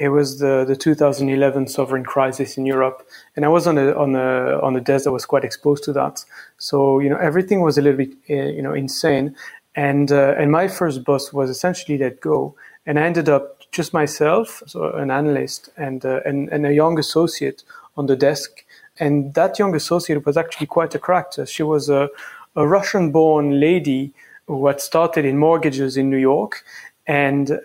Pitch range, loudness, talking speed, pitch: 140-155 Hz, -19 LUFS, 200 wpm, 145 Hz